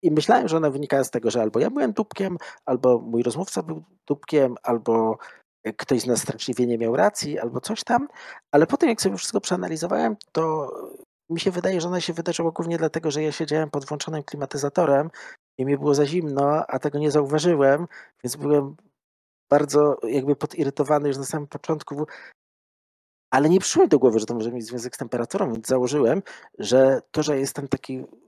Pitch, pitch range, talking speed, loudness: 150 Hz, 135-170 Hz, 185 wpm, -23 LUFS